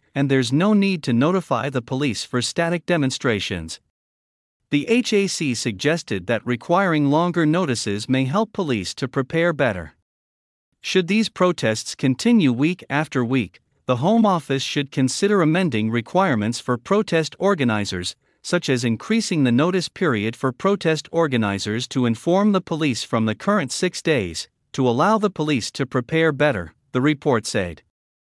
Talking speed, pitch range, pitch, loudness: 145 wpm, 120-175 Hz, 140 Hz, -21 LUFS